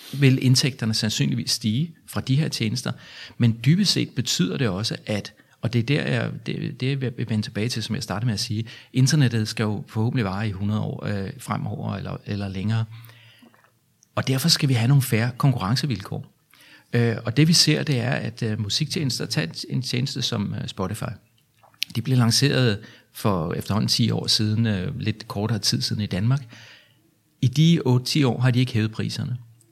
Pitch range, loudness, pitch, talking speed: 110-135 Hz, -23 LUFS, 120 Hz, 180 wpm